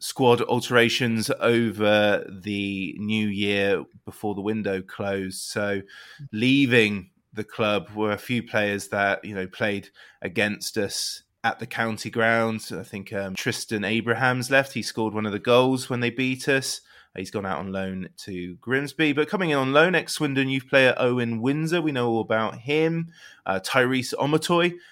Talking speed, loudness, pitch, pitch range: 170 wpm, -24 LUFS, 115 Hz, 105-130 Hz